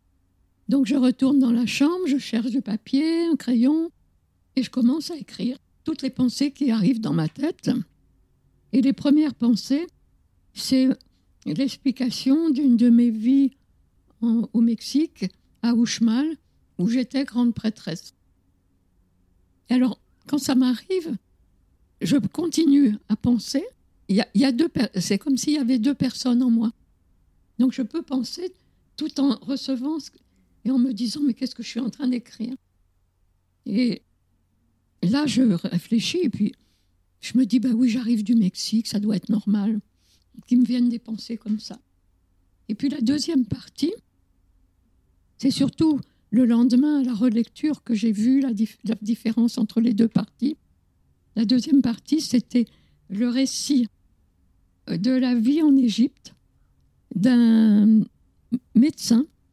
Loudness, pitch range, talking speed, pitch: -22 LUFS, 220-270 Hz, 155 wpm, 245 Hz